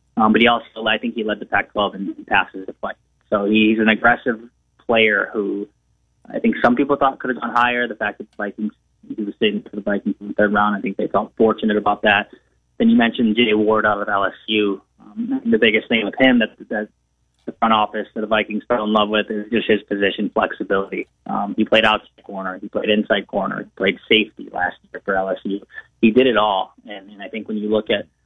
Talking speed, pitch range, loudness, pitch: 230 wpm, 105-115 Hz, -19 LUFS, 110 Hz